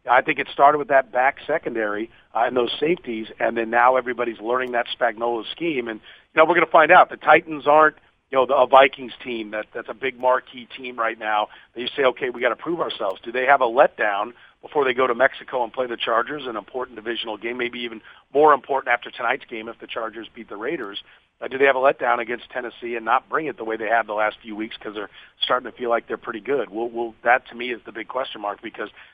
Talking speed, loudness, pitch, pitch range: 255 wpm, -21 LUFS, 120 Hz, 115-135 Hz